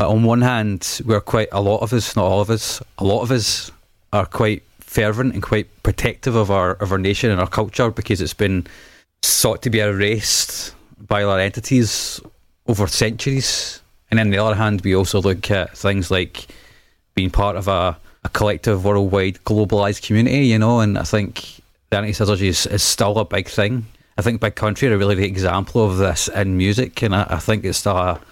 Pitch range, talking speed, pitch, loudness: 95-110 Hz, 205 wpm, 105 Hz, -18 LUFS